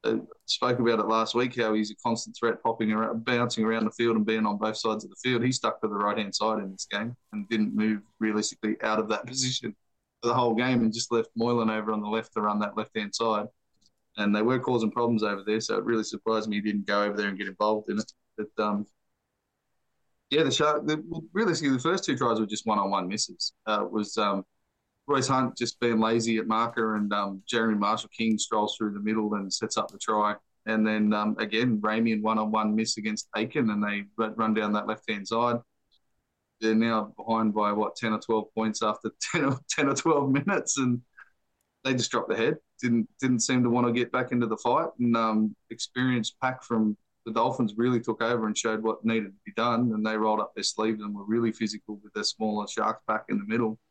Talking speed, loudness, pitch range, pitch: 230 wpm, -27 LUFS, 105-120 Hz, 110 Hz